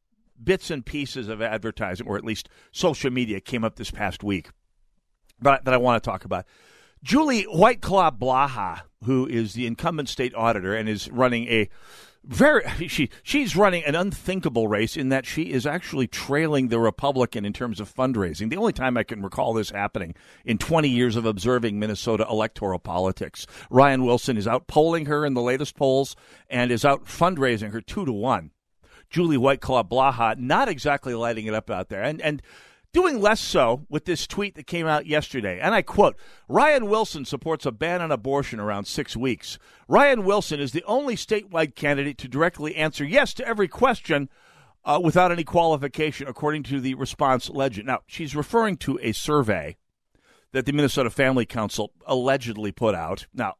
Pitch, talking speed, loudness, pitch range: 135 Hz, 180 wpm, -23 LUFS, 115-155 Hz